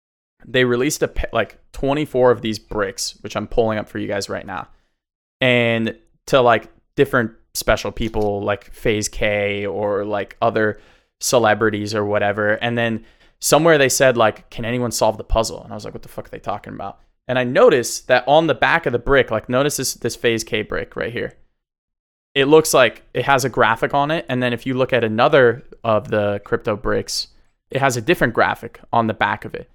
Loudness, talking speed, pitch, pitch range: -18 LUFS, 210 wpm, 115 Hz, 105-130 Hz